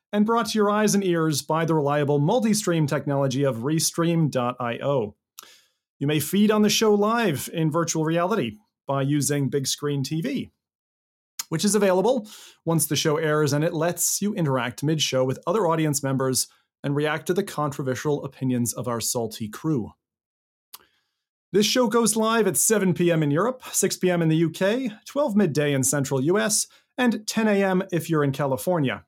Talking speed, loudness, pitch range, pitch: 175 wpm, -23 LUFS, 140-200 Hz, 160 Hz